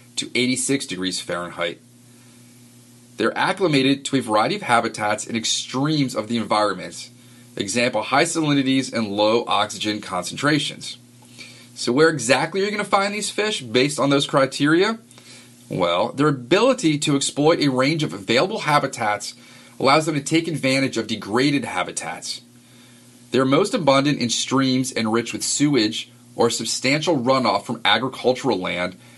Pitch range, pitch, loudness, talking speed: 115-140 Hz, 120 Hz, -20 LUFS, 140 wpm